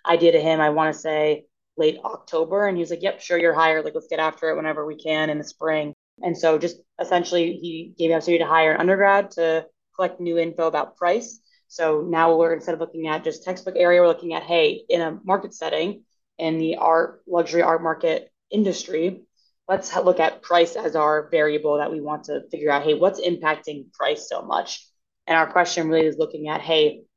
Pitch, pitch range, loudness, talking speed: 165 Hz, 155-180 Hz, -22 LUFS, 215 wpm